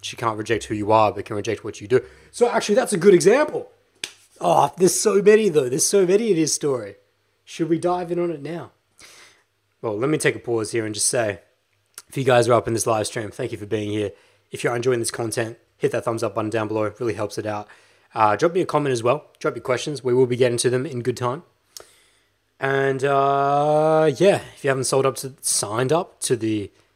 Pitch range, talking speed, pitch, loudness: 115-170 Hz, 245 wpm, 125 Hz, -21 LUFS